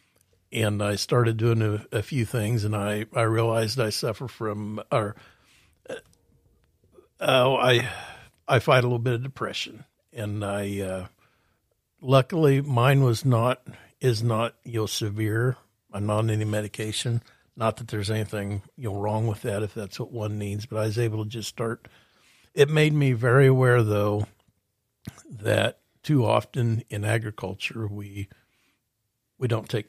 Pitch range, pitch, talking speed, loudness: 105-125 Hz, 115 Hz, 160 wpm, -25 LUFS